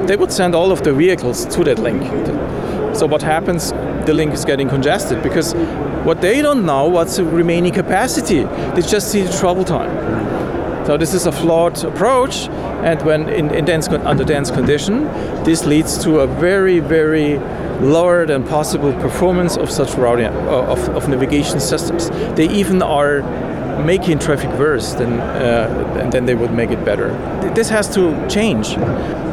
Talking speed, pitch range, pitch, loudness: 170 wpm, 145-180 Hz, 165 Hz, -16 LUFS